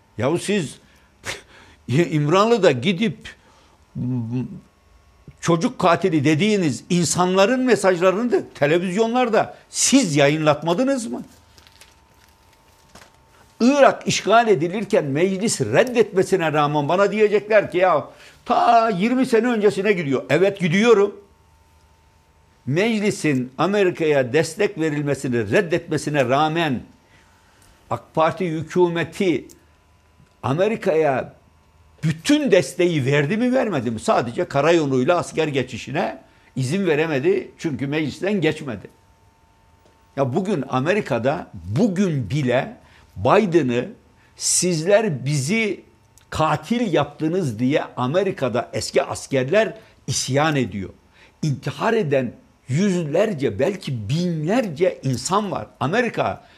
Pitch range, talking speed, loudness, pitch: 125-200 Hz, 85 wpm, -20 LUFS, 155 Hz